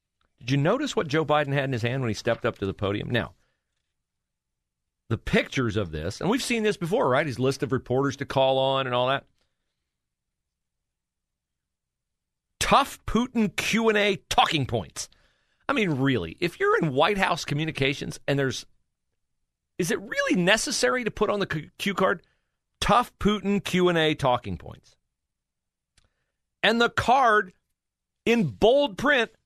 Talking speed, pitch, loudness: 155 wpm, 135 Hz, -24 LUFS